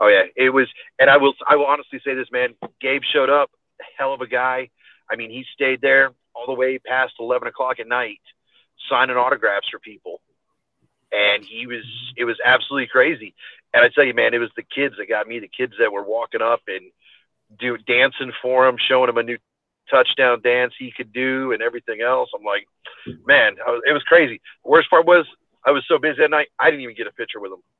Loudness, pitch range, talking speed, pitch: -18 LUFS, 125-140 Hz, 225 wpm, 130 Hz